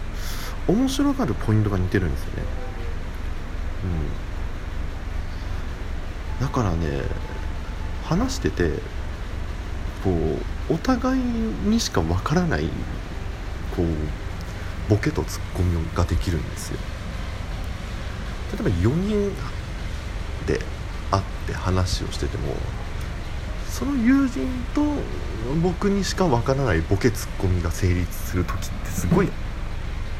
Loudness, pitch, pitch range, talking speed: -26 LUFS, 90 Hz, 80-100 Hz, 205 characters per minute